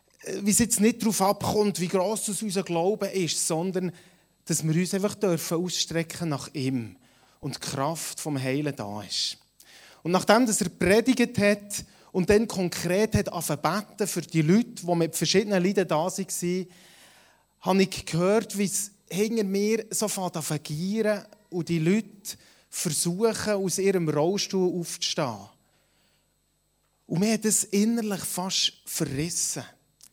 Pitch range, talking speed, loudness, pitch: 165-205 Hz, 145 wpm, -26 LUFS, 185 Hz